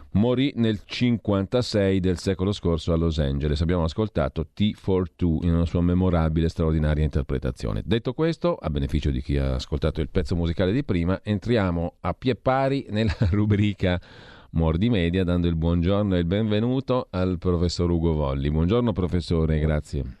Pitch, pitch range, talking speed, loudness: 90 Hz, 80-105 Hz, 160 wpm, -24 LUFS